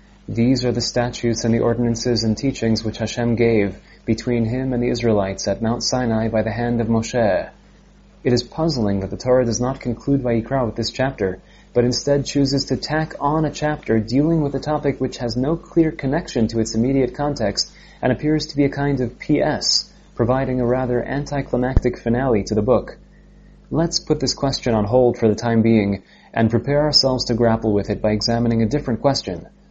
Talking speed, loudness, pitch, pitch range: 200 wpm, -20 LUFS, 120 Hz, 115-135 Hz